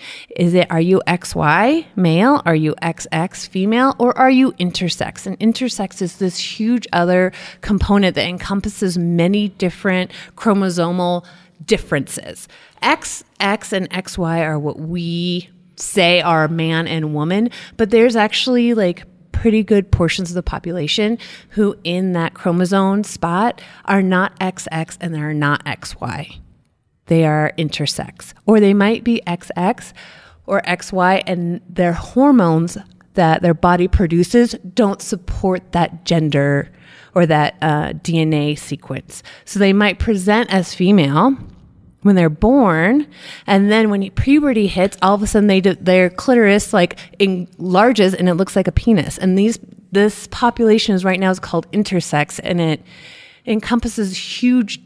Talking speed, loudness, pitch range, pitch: 140 wpm, -16 LUFS, 170-210 Hz, 185 Hz